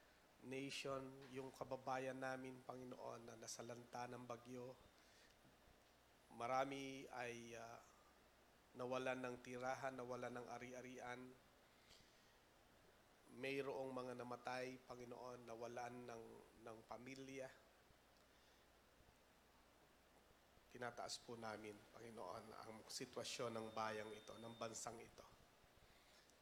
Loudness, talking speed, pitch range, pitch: -52 LUFS, 85 wpm, 115-130 Hz, 125 Hz